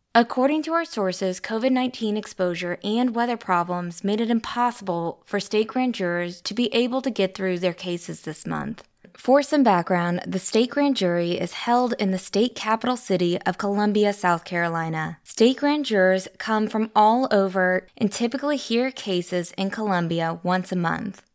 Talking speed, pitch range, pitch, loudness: 170 wpm, 180-235 Hz, 205 Hz, -23 LUFS